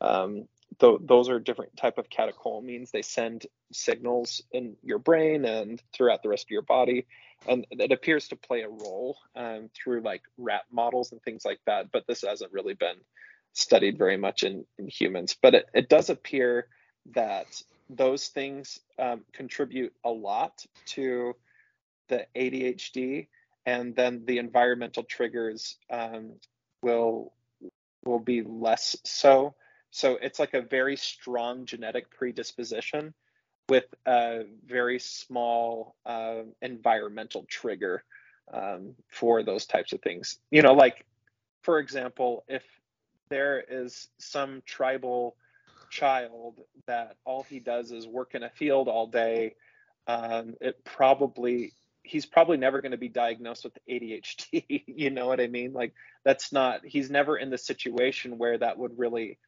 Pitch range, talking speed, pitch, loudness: 120-135 Hz, 145 wpm, 125 Hz, -28 LUFS